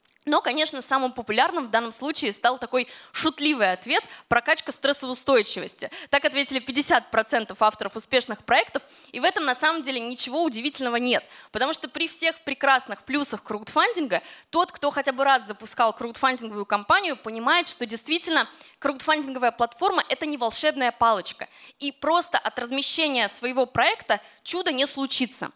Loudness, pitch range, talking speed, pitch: -23 LUFS, 235-305 Hz, 145 wpm, 265 Hz